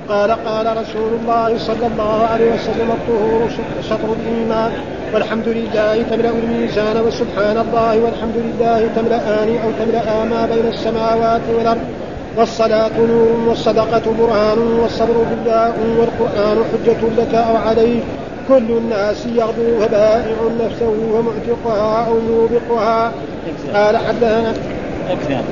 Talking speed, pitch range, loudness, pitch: 115 wpm, 220-230 Hz, -16 LUFS, 230 Hz